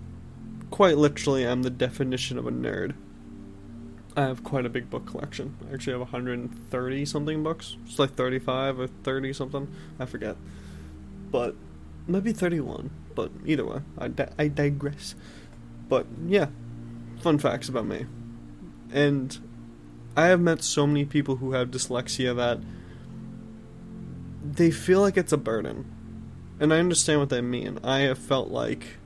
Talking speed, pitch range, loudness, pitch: 150 wpm, 115-145 Hz, -27 LUFS, 130 Hz